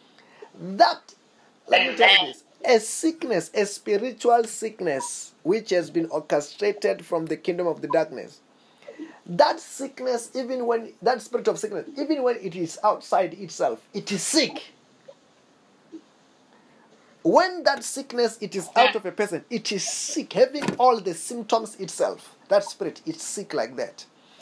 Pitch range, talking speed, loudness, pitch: 195-280 Hz, 150 wpm, -24 LUFS, 230 Hz